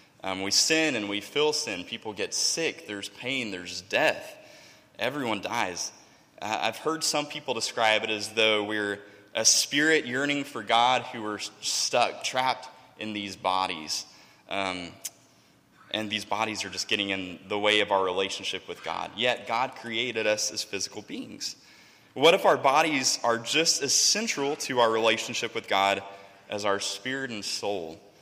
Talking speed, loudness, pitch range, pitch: 165 wpm, -26 LUFS, 100-125 Hz, 105 Hz